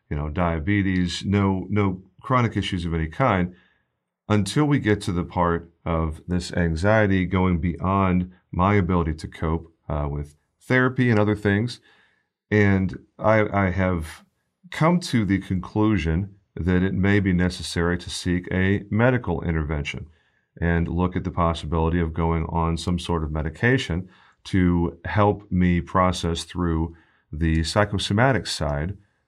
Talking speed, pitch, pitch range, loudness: 140 wpm, 90 Hz, 85-100 Hz, -23 LUFS